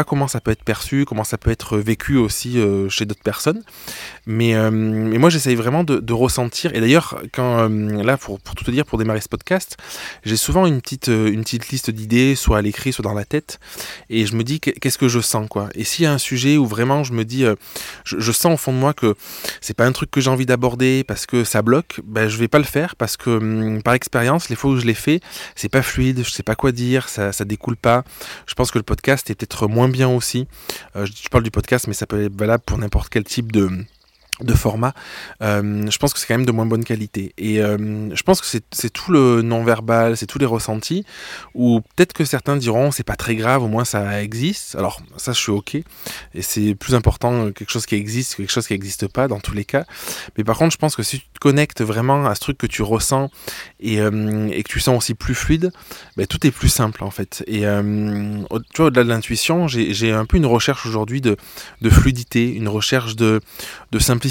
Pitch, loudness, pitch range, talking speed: 115 Hz, -19 LUFS, 110-130 Hz, 245 wpm